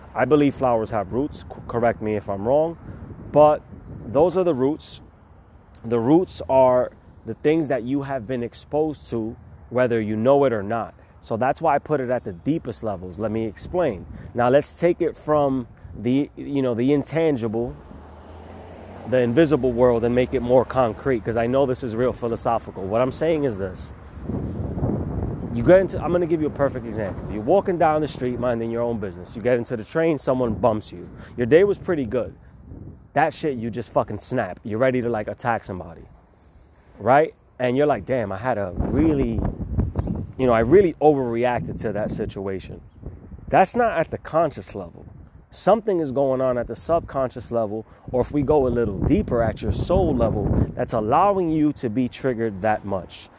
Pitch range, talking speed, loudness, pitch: 105-140 Hz, 190 wpm, -22 LUFS, 120 Hz